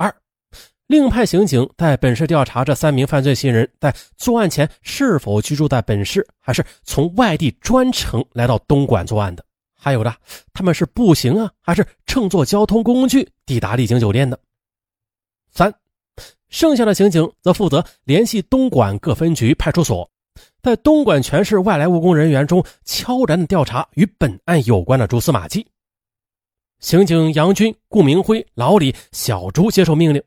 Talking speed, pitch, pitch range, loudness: 250 characters per minute, 155 Hz, 120-200 Hz, -16 LUFS